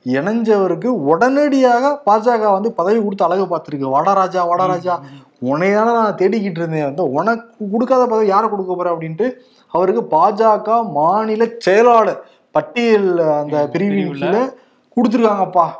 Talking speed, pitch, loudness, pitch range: 115 wpm, 205 Hz, -16 LUFS, 180-230 Hz